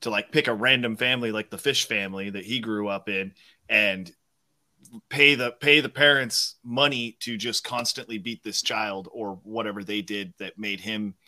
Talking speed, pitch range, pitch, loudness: 185 wpm, 100-125 Hz, 110 Hz, -24 LUFS